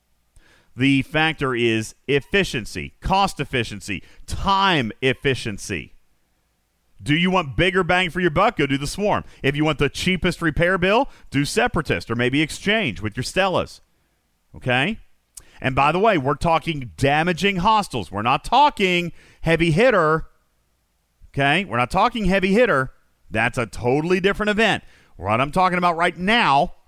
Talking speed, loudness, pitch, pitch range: 145 wpm, -20 LUFS, 150 Hz, 125-185 Hz